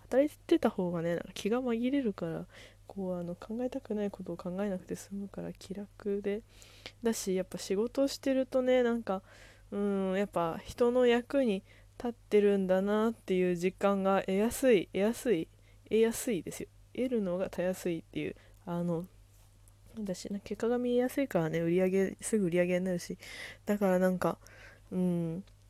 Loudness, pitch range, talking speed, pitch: -32 LUFS, 170-225 Hz, 340 characters per minute, 190 Hz